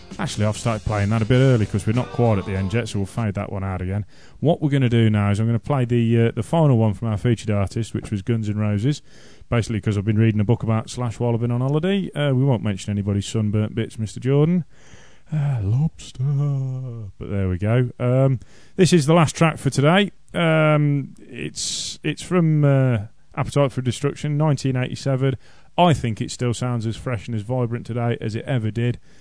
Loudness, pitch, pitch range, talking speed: -21 LUFS, 120 Hz, 110-140 Hz, 225 wpm